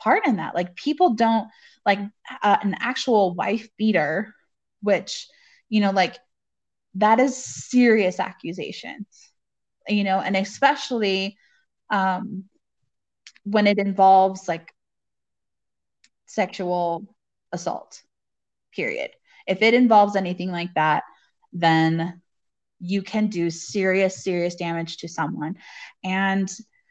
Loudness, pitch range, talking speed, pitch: -22 LUFS, 180-225 Hz, 105 wpm, 195 Hz